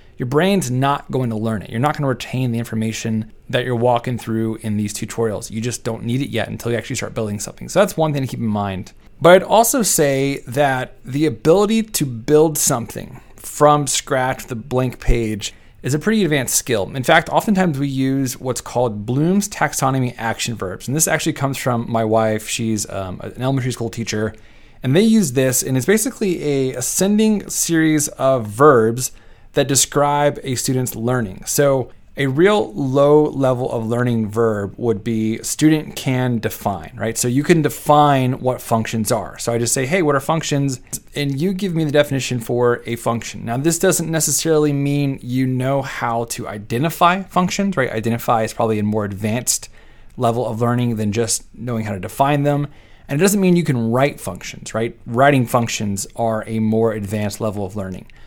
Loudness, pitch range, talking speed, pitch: -18 LUFS, 115-145 Hz, 190 wpm, 125 Hz